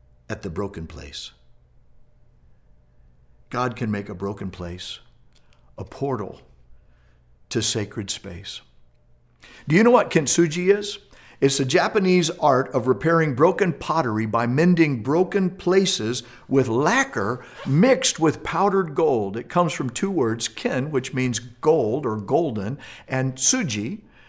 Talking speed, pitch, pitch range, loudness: 130 wpm, 130 Hz, 100-170 Hz, -22 LUFS